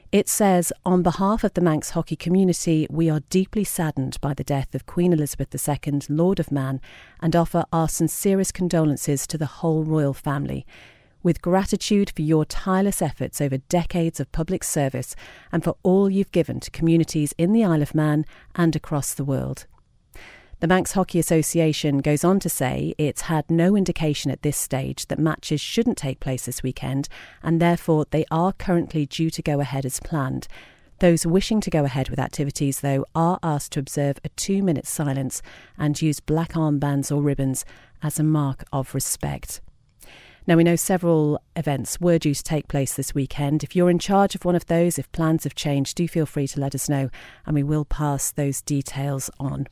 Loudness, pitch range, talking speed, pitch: -23 LUFS, 140-170 Hz, 190 wpm, 155 Hz